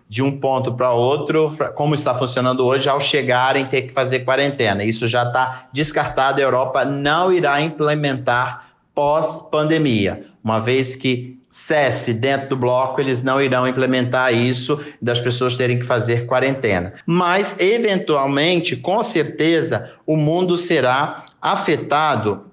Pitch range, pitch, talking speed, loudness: 125-150 Hz, 130 Hz, 135 wpm, -18 LUFS